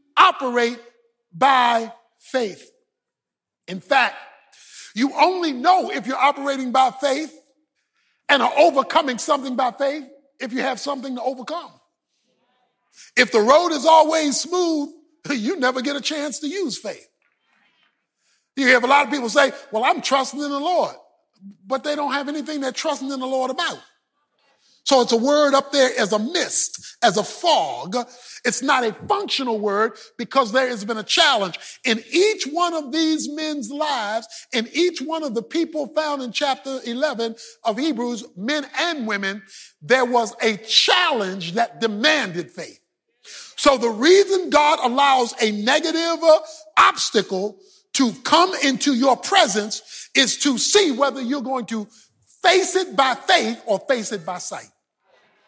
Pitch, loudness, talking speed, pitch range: 275 Hz, -19 LUFS, 155 wpm, 235-305 Hz